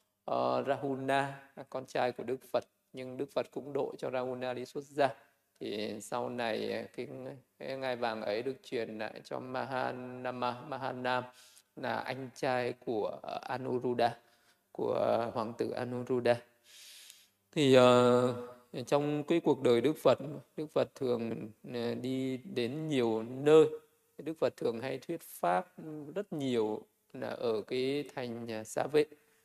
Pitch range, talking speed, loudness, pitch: 120-140 Hz, 145 wpm, -33 LUFS, 125 Hz